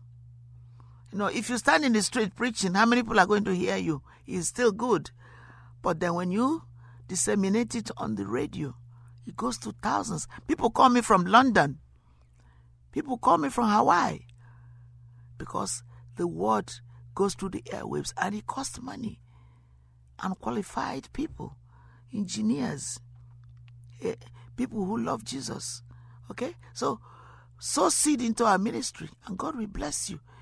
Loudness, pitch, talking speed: -28 LUFS, 120 Hz, 145 wpm